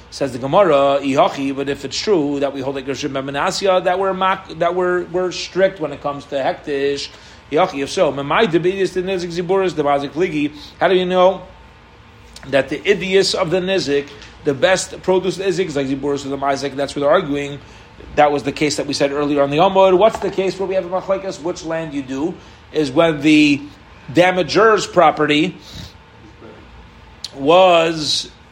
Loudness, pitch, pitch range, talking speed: -17 LUFS, 150 Hz, 140-185 Hz, 155 wpm